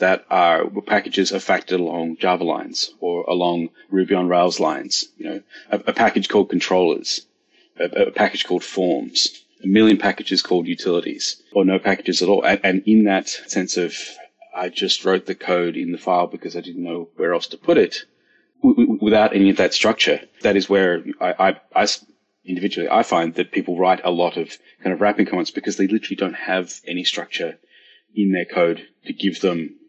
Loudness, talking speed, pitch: -19 LUFS, 195 wpm, 100 Hz